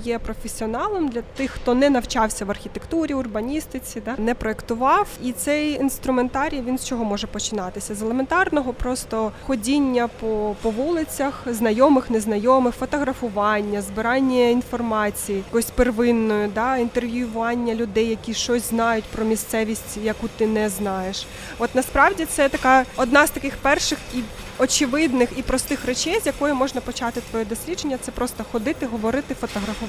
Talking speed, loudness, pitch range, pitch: 140 wpm, -22 LUFS, 225-270 Hz, 240 Hz